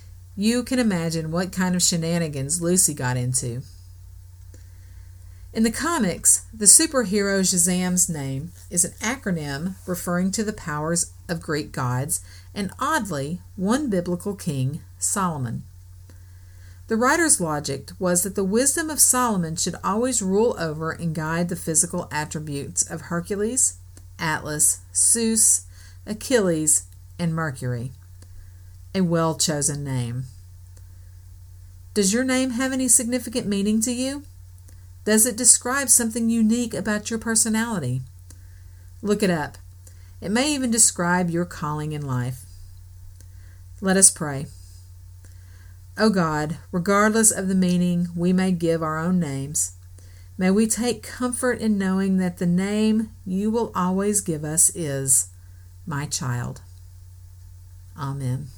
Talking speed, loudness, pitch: 125 wpm, -21 LUFS, 155 Hz